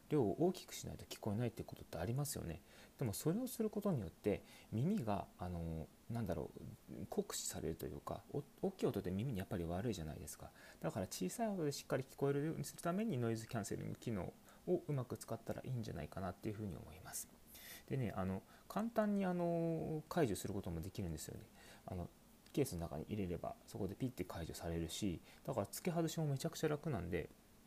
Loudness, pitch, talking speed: -43 LUFS, 115 Hz, 435 characters per minute